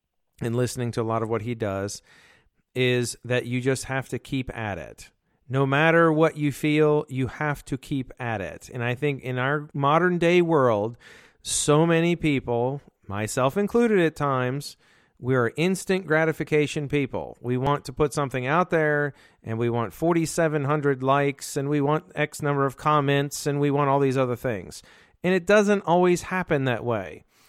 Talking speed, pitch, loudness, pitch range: 180 wpm, 140 Hz, -24 LUFS, 125-155 Hz